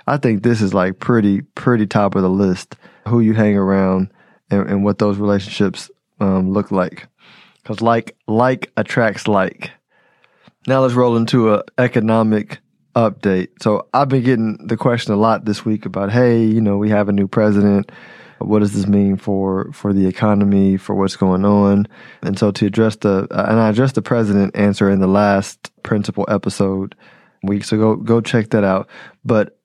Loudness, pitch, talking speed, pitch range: -16 LUFS, 105 Hz, 185 wpm, 100-115 Hz